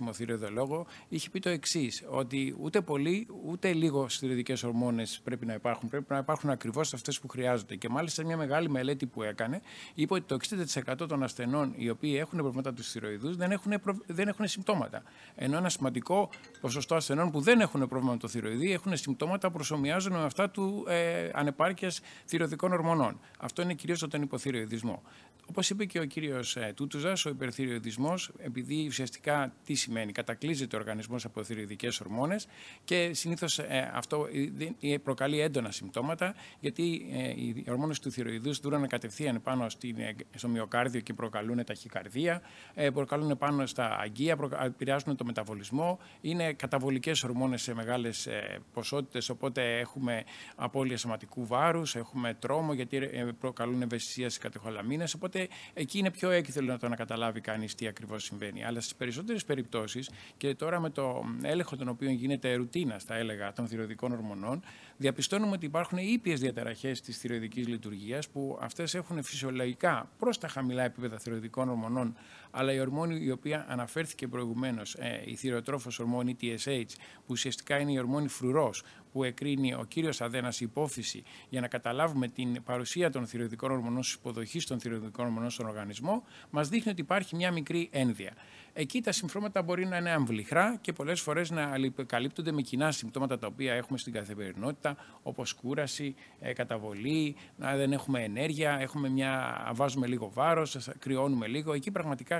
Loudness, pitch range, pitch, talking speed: -33 LUFS, 120-155 Hz, 135 Hz, 155 wpm